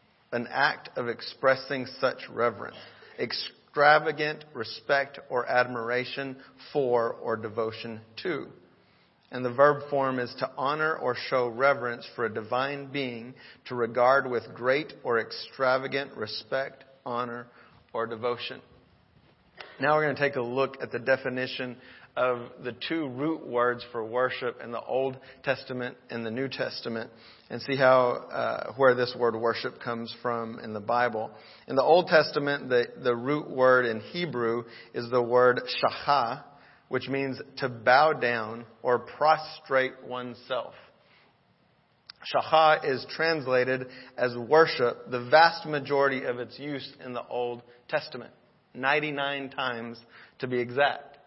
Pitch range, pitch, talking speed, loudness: 120-140 Hz, 130 Hz, 140 wpm, -27 LUFS